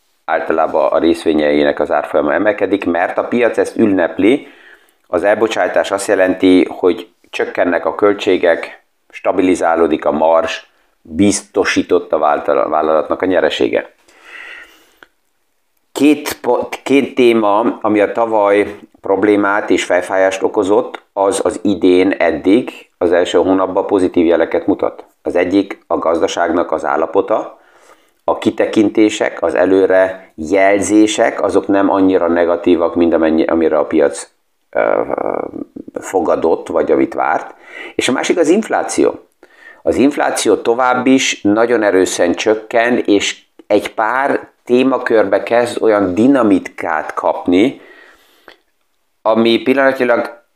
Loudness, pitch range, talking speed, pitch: -14 LUFS, 95-120 Hz, 115 wpm, 100 Hz